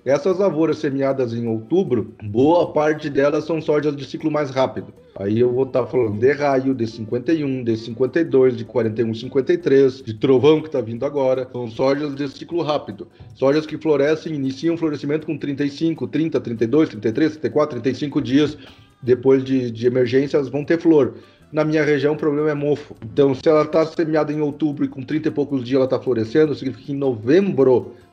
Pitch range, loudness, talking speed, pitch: 130-155 Hz, -20 LUFS, 190 wpm, 140 Hz